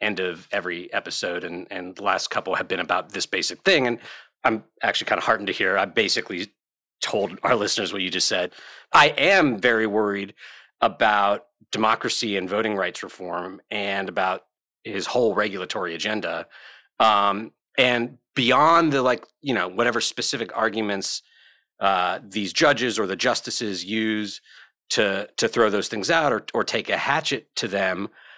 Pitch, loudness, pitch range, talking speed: 105 Hz, -23 LUFS, 100-120 Hz, 165 wpm